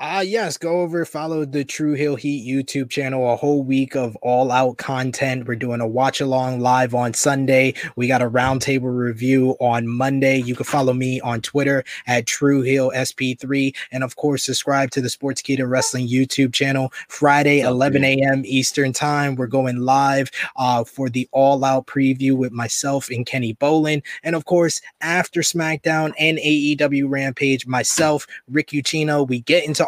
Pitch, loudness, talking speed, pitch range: 135 Hz, -19 LUFS, 175 wpm, 130-145 Hz